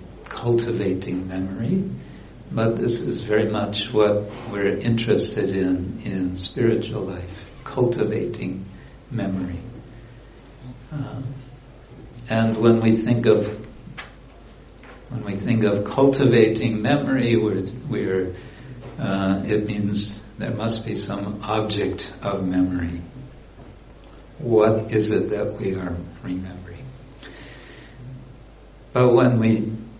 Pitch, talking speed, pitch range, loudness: 110 Hz, 100 wpm, 100-120 Hz, -22 LUFS